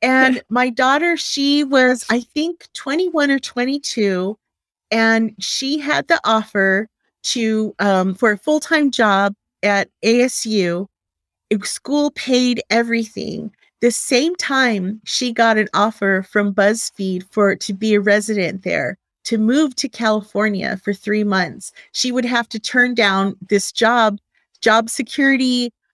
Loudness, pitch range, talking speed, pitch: -17 LUFS, 205-255 Hz, 135 wpm, 225 Hz